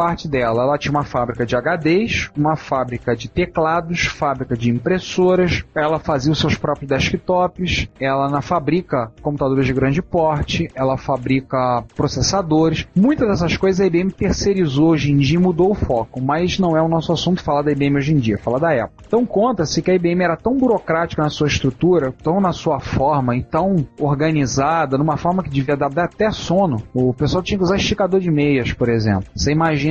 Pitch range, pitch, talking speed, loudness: 135-175 Hz, 155 Hz, 195 wpm, -18 LUFS